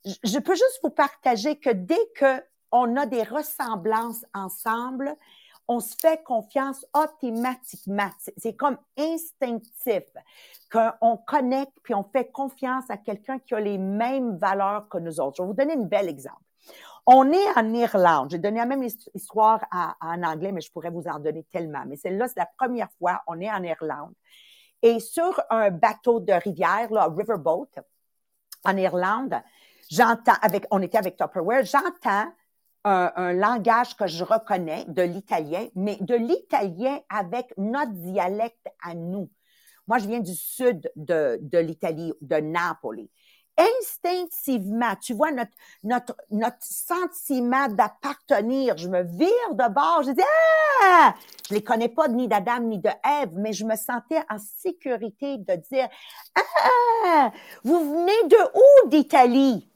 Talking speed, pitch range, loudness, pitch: 155 wpm, 195-280 Hz, -23 LUFS, 235 Hz